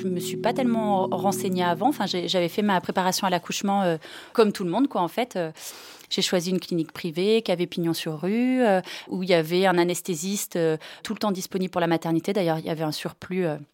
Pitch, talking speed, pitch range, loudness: 185 Hz, 245 wpm, 175-200 Hz, -25 LUFS